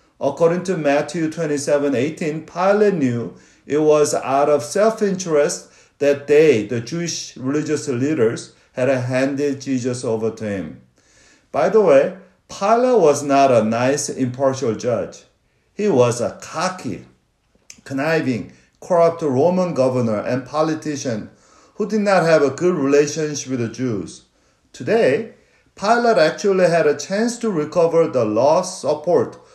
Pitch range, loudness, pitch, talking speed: 130-175 Hz, -18 LUFS, 150 Hz, 135 wpm